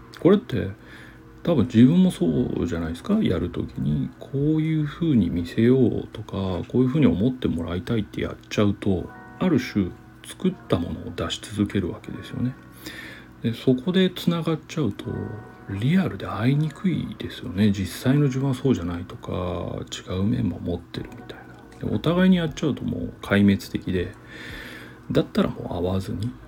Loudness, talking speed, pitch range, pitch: -24 LUFS, 355 characters per minute, 90-130 Hz, 110 Hz